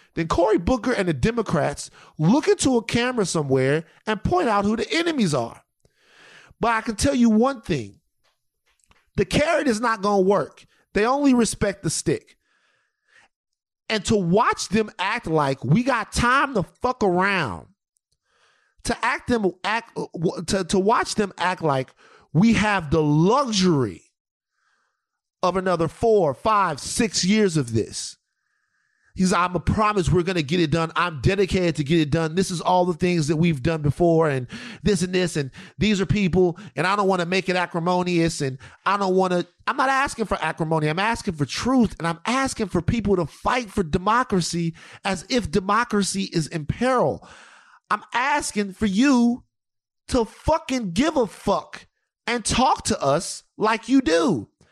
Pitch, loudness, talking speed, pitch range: 195 Hz, -22 LUFS, 170 wpm, 165-230 Hz